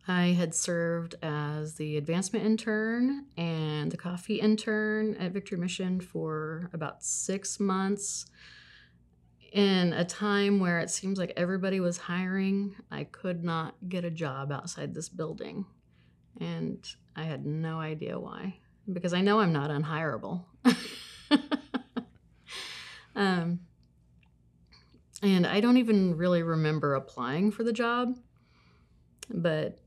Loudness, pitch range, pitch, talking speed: -30 LUFS, 155-200 Hz, 175 Hz, 125 wpm